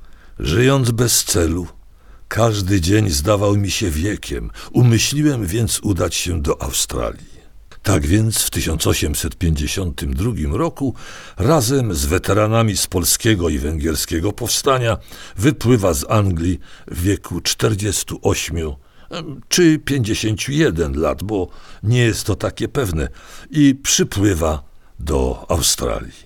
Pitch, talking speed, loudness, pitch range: 100 Hz, 105 wpm, -18 LUFS, 80-115 Hz